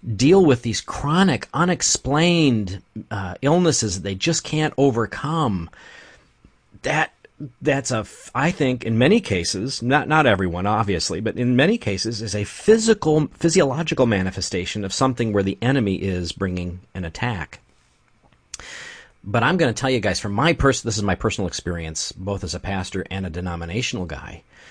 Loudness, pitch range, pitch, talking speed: -21 LUFS, 95-140 Hz, 115 Hz, 165 wpm